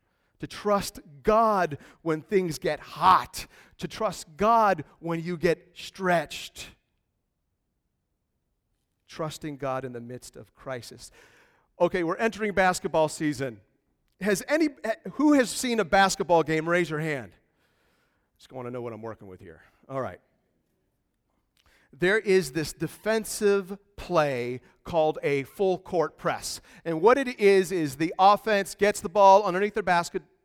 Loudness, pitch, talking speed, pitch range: -25 LUFS, 175 Hz, 140 wpm, 150-205 Hz